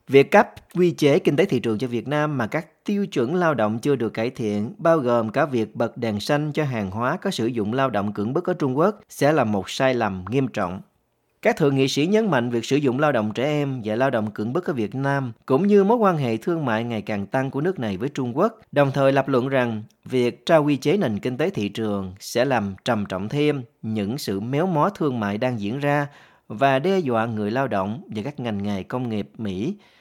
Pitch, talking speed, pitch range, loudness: 130 Hz, 250 wpm, 110-150 Hz, -22 LUFS